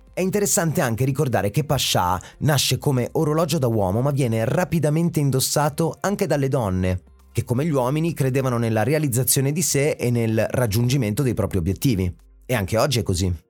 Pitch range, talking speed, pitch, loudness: 115-155 Hz, 170 wpm, 130 Hz, -21 LUFS